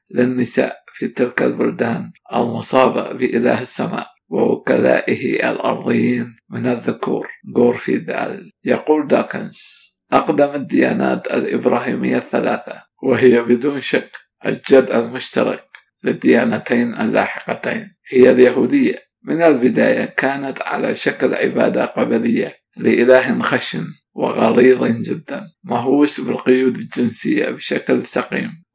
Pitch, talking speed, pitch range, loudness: 130 Hz, 90 wpm, 120-145 Hz, -17 LUFS